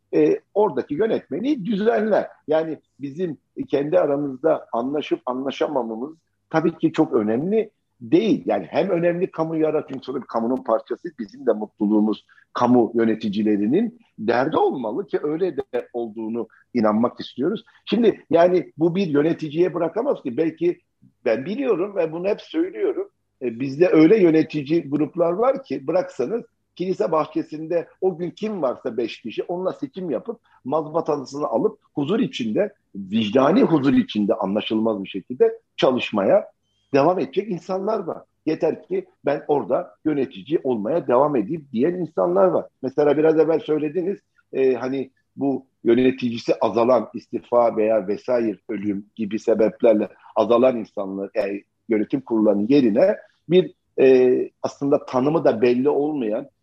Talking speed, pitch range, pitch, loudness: 125 wpm, 125-190 Hz, 155 Hz, -22 LUFS